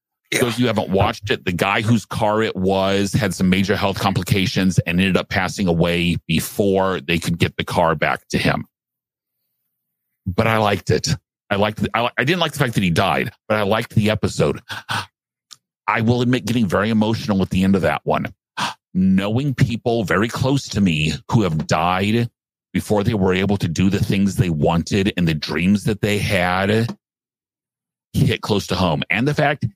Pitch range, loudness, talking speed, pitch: 95-115 Hz, -19 LUFS, 200 wpm, 105 Hz